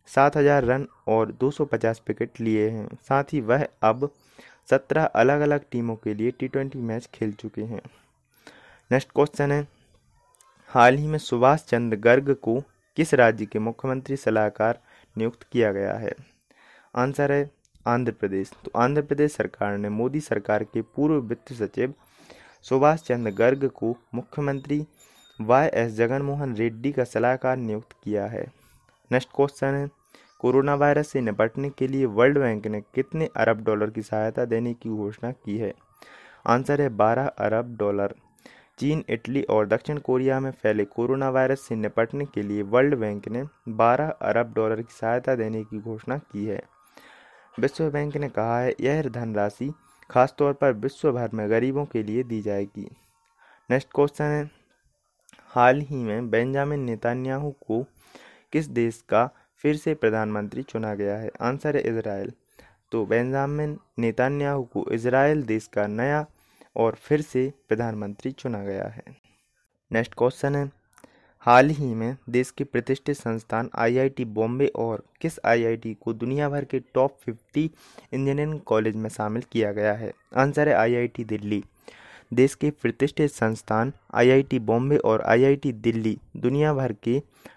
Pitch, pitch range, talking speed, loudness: 125 Hz, 110-140 Hz, 150 wpm, -25 LUFS